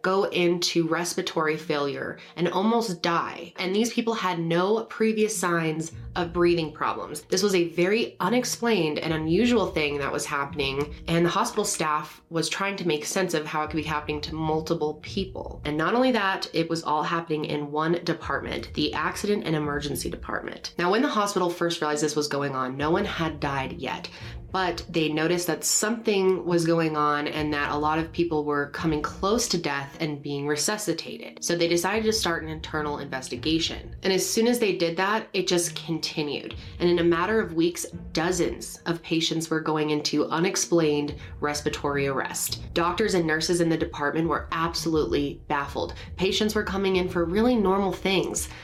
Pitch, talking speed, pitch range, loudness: 165 Hz, 185 wpm, 150-185 Hz, -26 LUFS